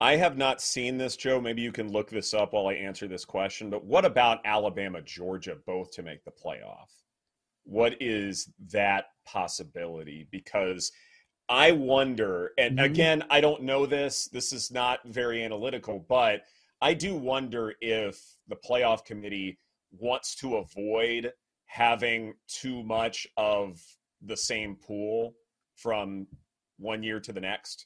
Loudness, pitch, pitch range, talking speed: -28 LUFS, 115 Hz, 100-125 Hz, 150 wpm